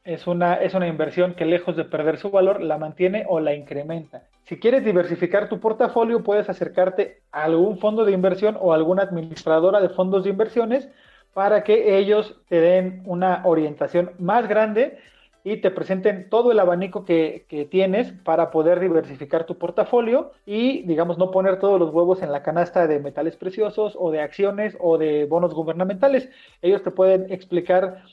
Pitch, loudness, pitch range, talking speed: 185 Hz, -21 LUFS, 170-210 Hz, 175 wpm